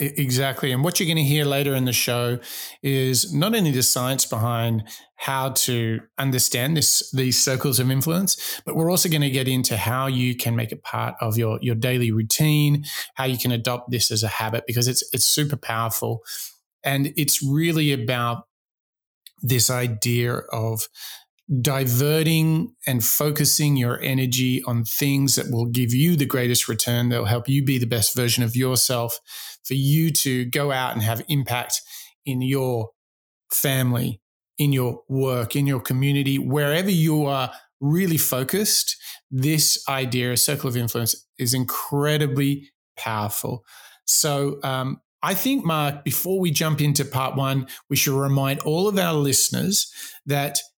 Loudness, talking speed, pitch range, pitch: -21 LUFS, 160 wpm, 120-145 Hz, 130 Hz